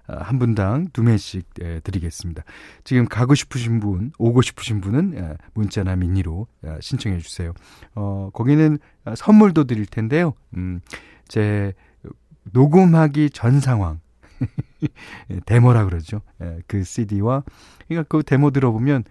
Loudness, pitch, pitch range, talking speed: -19 LUFS, 110 Hz, 95-135 Hz, 245 characters per minute